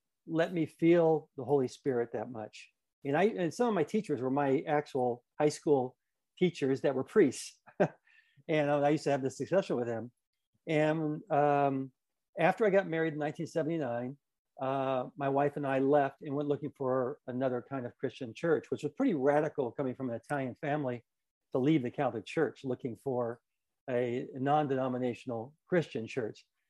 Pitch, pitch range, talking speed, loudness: 140 Hz, 125-155 Hz, 170 wpm, -32 LUFS